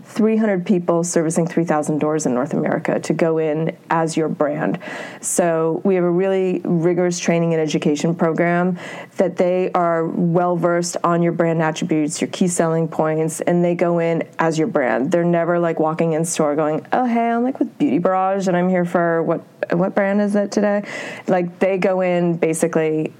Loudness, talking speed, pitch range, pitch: -19 LUFS, 190 wpm, 160-185 Hz, 170 Hz